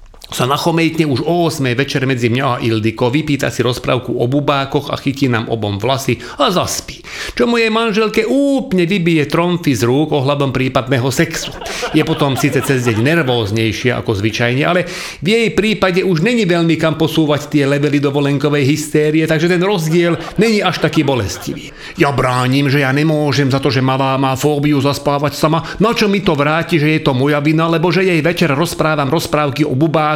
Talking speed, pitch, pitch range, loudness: 185 wpm, 150 Hz, 135-170 Hz, -14 LUFS